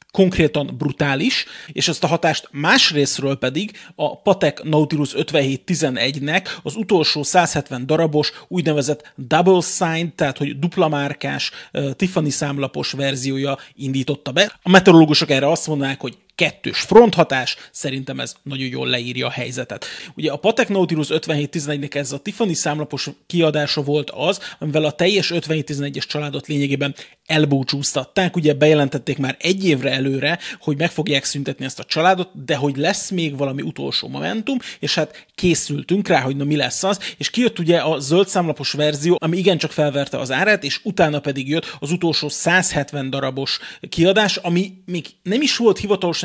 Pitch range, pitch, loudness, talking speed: 140-180 Hz, 155 Hz, -19 LUFS, 155 wpm